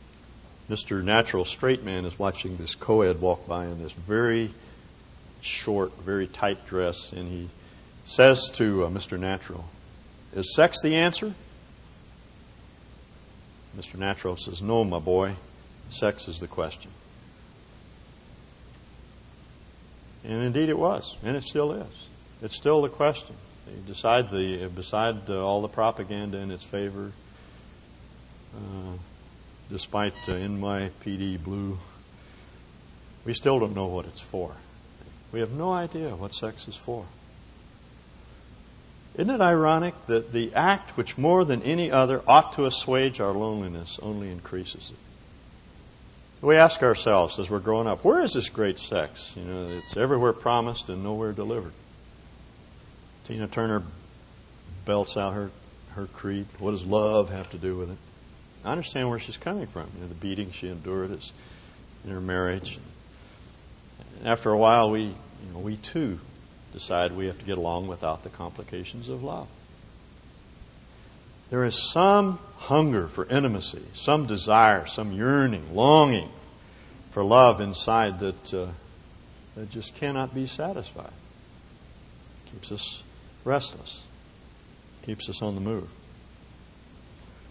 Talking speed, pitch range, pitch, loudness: 140 wpm, 90-115 Hz, 100 Hz, -26 LUFS